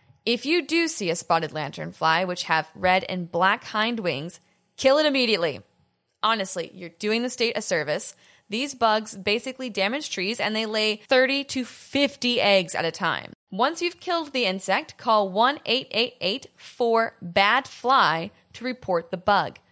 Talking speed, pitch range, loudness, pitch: 165 wpm, 185-255 Hz, -24 LUFS, 215 Hz